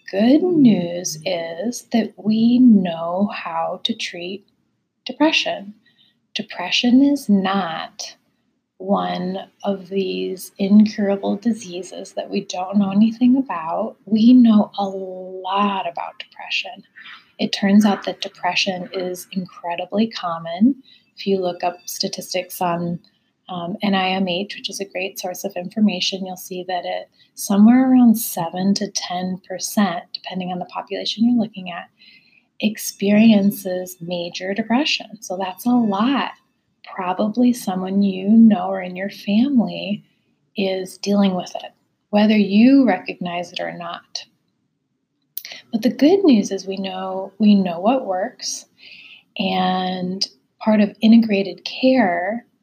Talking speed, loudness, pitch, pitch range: 125 wpm, -19 LUFS, 200 Hz, 185-225 Hz